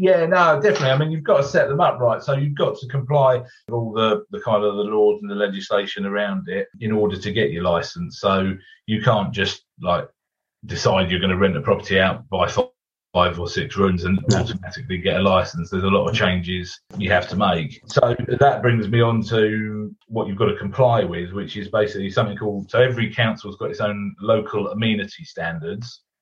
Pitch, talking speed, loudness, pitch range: 110 Hz, 215 wpm, -20 LUFS, 100-130 Hz